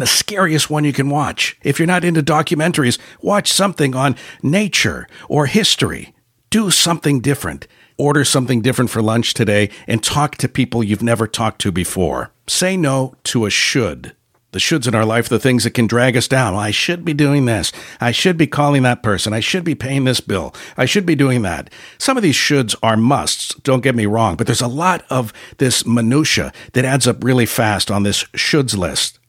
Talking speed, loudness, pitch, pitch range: 205 wpm, -16 LUFS, 130 Hz, 115-150 Hz